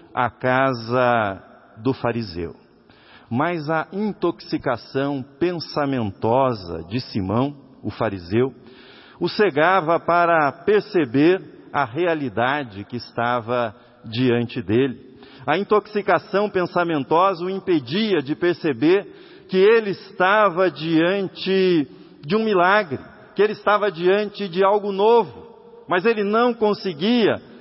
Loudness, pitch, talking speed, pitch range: -21 LUFS, 165 Hz, 100 wpm, 125-200 Hz